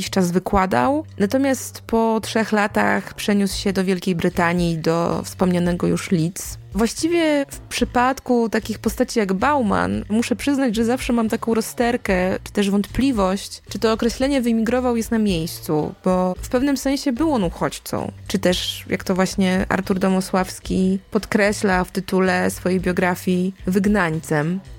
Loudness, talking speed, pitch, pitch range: -20 LUFS, 145 wpm, 200 Hz, 185-235 Hz